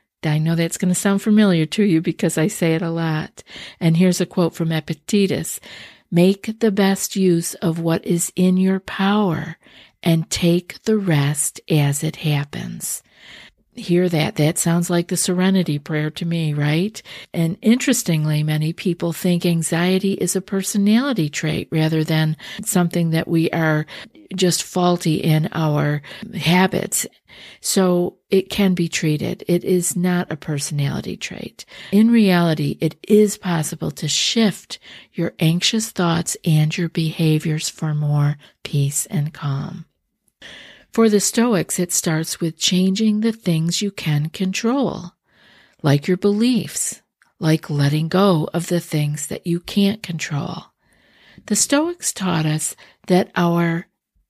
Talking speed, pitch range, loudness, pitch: 145 wpm, 160-190 Hz, -19 LUFS, 175 Hz